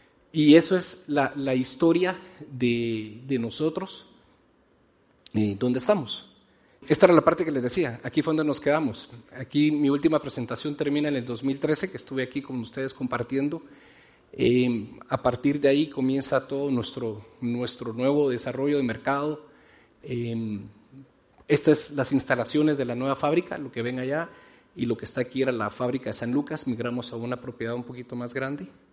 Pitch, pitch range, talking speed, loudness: 135 Hz, 120-145 Hz, 175 wpm, -26 LUFS